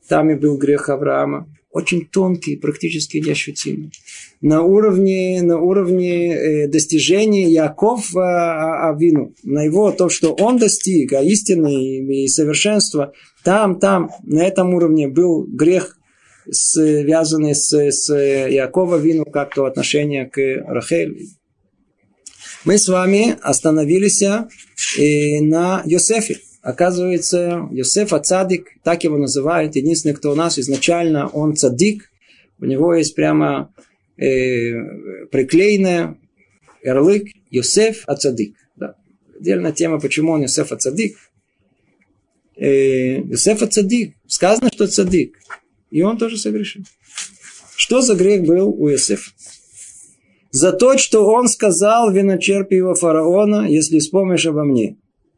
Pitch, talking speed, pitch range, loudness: 165 Hz, 115 wpm, 145-195 Hz, -16 LUFS